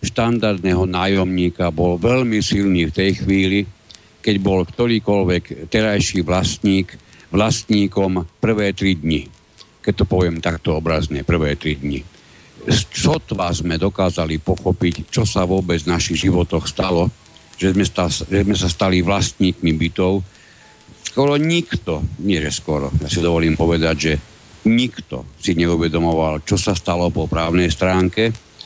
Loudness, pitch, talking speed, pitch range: -18 LUFS, 90 Hz, 135 wpm, 85-100 Hz